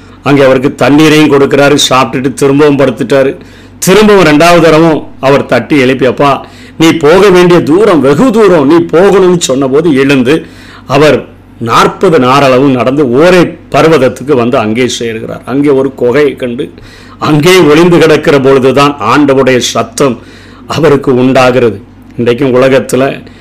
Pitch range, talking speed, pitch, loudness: 125-155 Hz, 120 wpm, 140 Hz, -6 LUFS